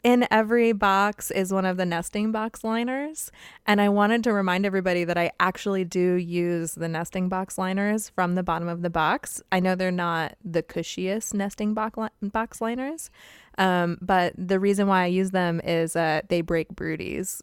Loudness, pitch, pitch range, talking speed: -25 LUFS, 185 Hz, 175-210 Hz, 195 wpm